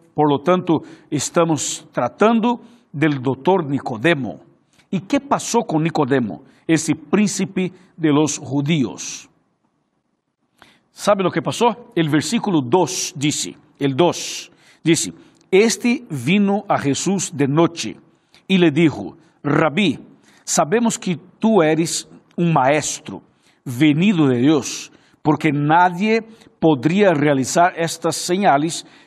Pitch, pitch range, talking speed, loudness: 165 Hz, 150-190 Hz, 110 wpm, -18 LUFS